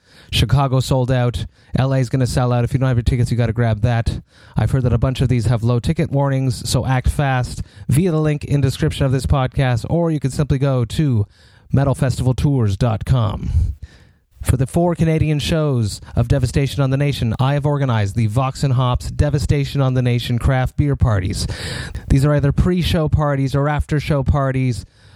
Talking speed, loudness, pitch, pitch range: 200 wpm, -18 LUFS, 130 Hz, 115-140 Hz